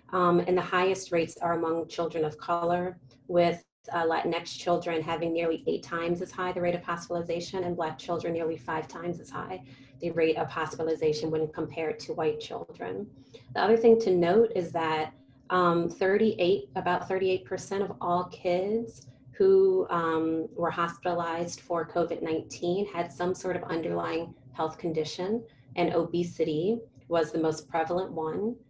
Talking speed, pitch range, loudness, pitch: 155 wpm, 160-180 Hz, -29 LUFS, 170 Hz